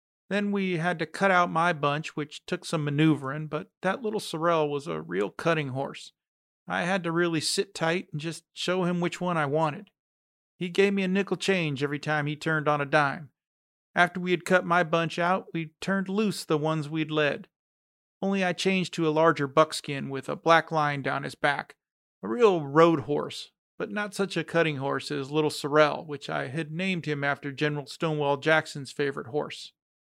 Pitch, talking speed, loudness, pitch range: 160 Hz, 200 wpm, -27 LUFS, 150-180 Hz